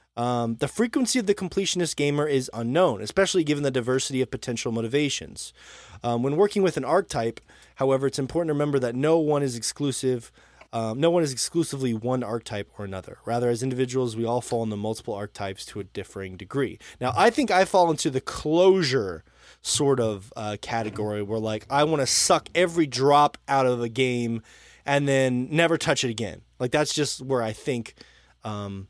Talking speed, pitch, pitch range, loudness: 190 wpm, 130 Hz, 115-150 Hz, -25 LUFS